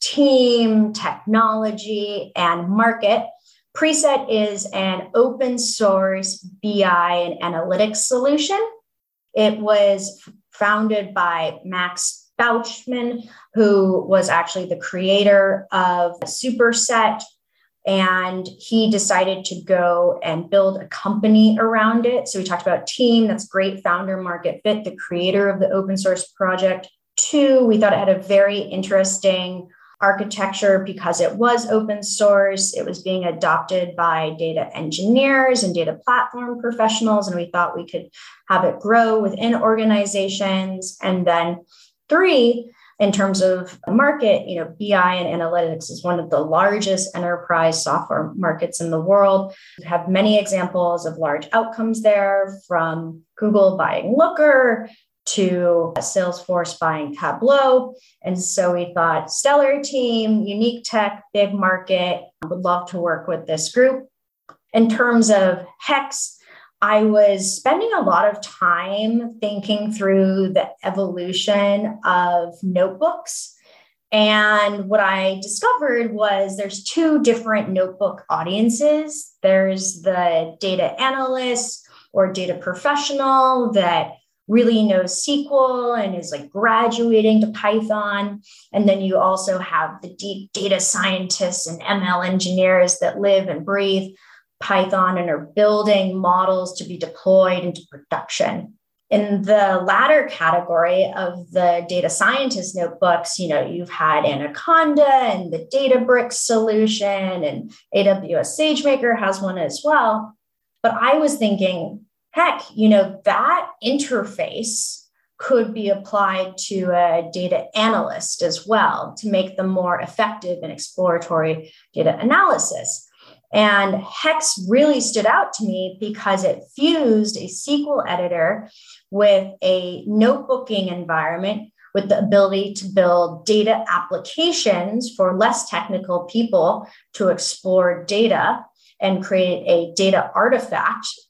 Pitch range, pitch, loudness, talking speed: 185-225 Hz, 200 Hz, -18 LUFS, 130 wpm